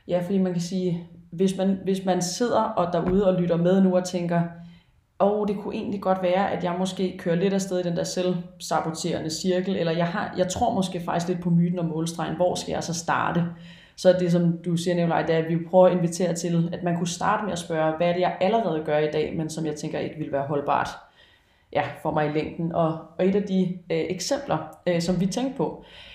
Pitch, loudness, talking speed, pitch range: 175 Hz, -25 LUFS, 250 wpm, 170-185 Hz